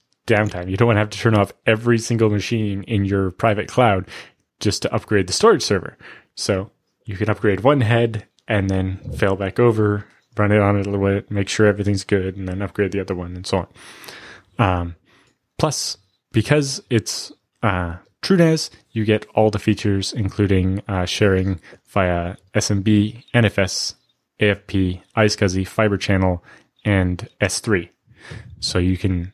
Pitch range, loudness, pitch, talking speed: 95-110 Hz, -20 LUFS, 105 Hz, 160 wpm